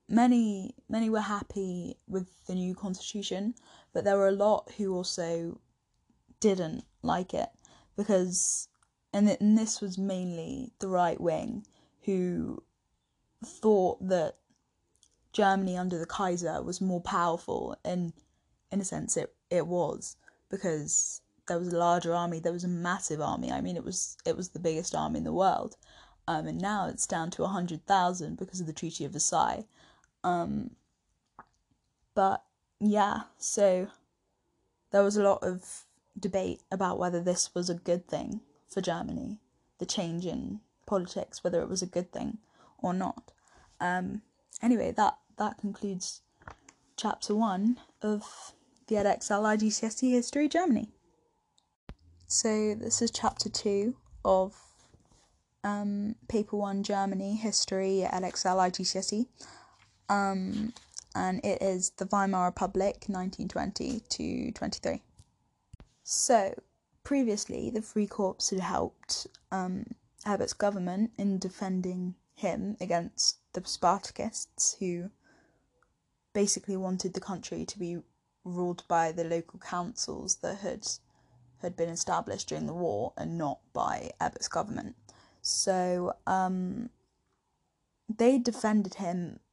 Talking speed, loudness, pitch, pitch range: 130 wpm, -31 LUFS, 195 Hz, 180-215 Hz